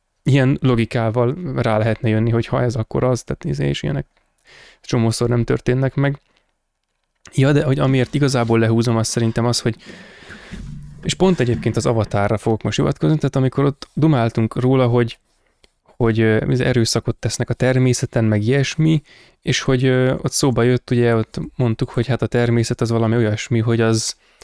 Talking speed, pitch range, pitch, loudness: 165 wpm, 115-135 Hz, 120 Hz, -18 LUFS